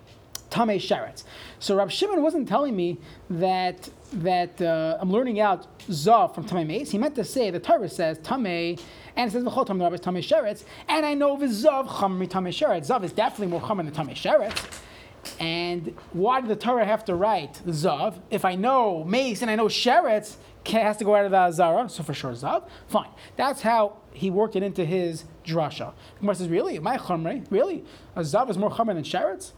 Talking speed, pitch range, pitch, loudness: 210 wpm, 175-235 Hz, 200 Hz, -25 LUFS